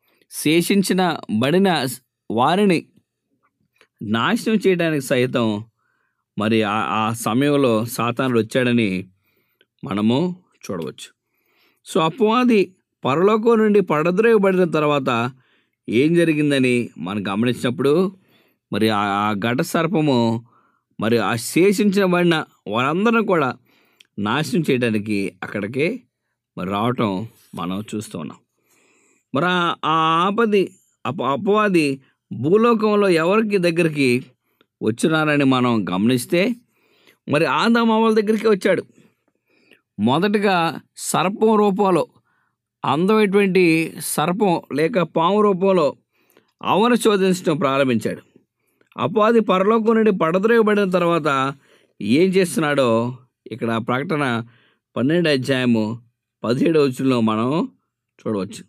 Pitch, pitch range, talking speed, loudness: 155 Hz, 120-195 Hz, 80 wpm, -19 LUFS